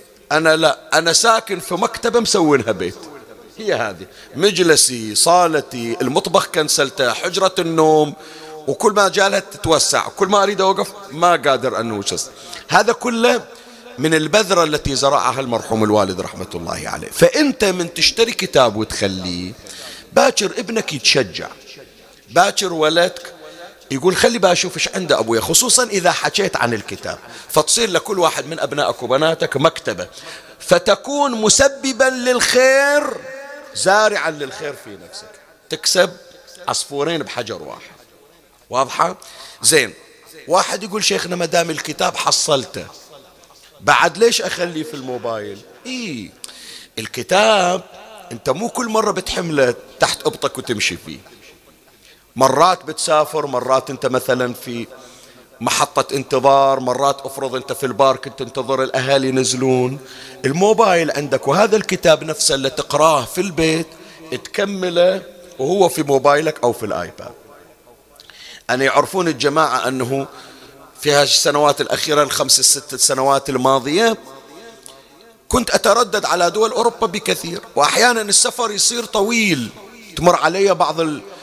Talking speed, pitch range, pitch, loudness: 115 wpm, 135-205 Hz, 165 Hz, -16 LUFS